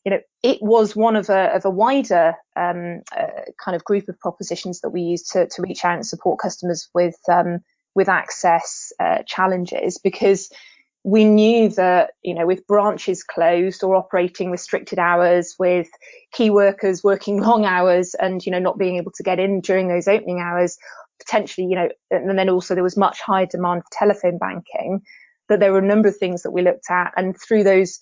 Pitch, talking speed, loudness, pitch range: 190 Hz, 200 wpm, -19 LUFS, 180-205 Hz